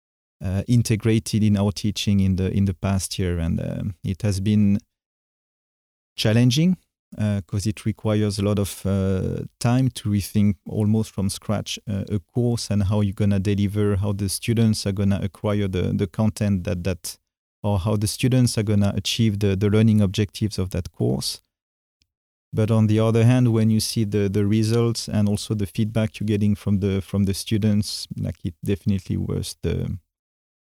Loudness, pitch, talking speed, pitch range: -22 LUFS, 105 Hz, 180 wpm, 100-110 Hz